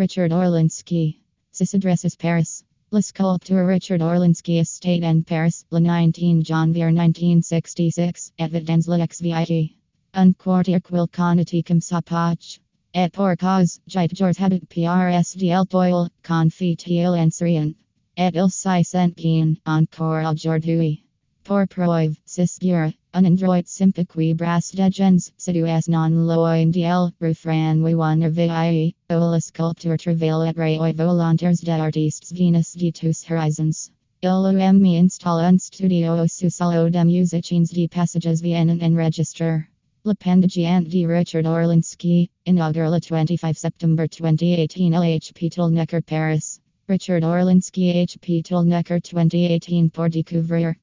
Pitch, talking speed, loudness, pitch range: 170 Hz, 130 wpm, -20 LUFS, 165-180 Hz